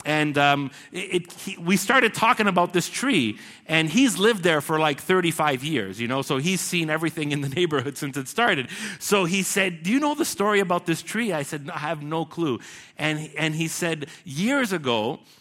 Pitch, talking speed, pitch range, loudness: 170 Hz, 215 wpm, 150-195 Hz, -23 LUFS